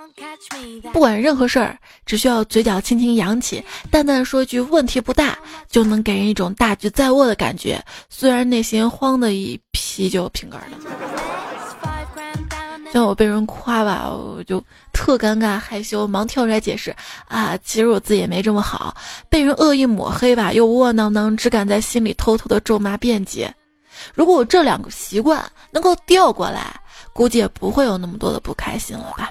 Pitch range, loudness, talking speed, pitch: 215-275 Hz, -18 LUFS, 265 characters per minute, 235 Hz